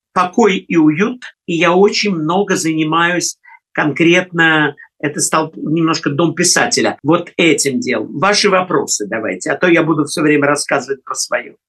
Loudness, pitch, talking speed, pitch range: -14 LUFS, 165 Hz, 150 wpm, 155-180 Hz